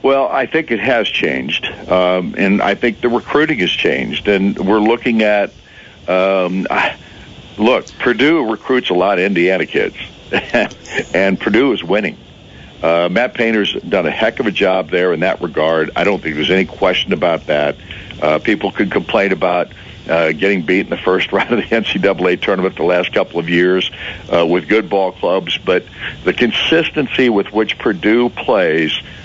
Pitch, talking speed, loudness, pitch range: 95 Hz, 175 wpm, -15 LUFS, 90-110 Hz